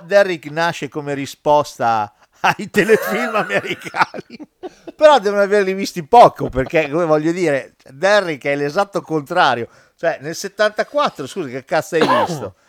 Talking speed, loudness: 130 wpm, -17 LUFS